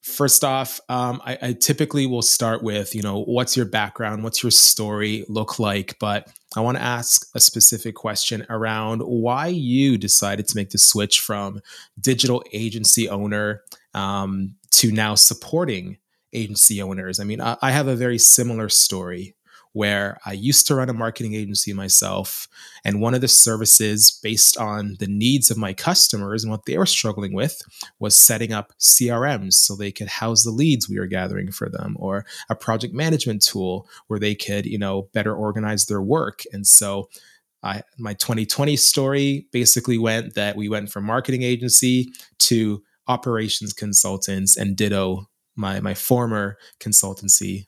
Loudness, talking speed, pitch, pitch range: -17 LUFS, 165 wpm, 110 Hz, 100-120 Hz